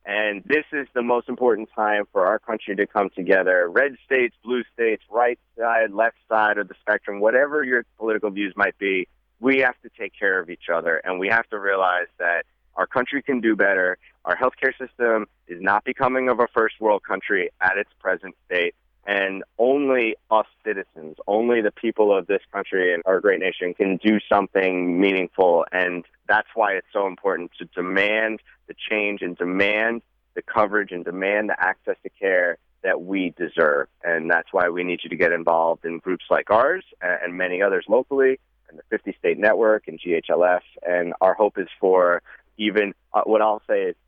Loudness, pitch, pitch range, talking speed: -22 LUFS, 105 Hz, 95-125 Hz, 190 wpm